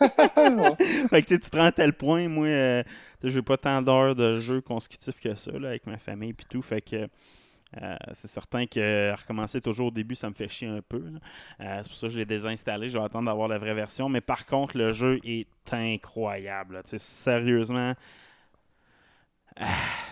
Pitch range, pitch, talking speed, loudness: 110-130 Hz, 120 Hz, 205 wpm, -27 LUFS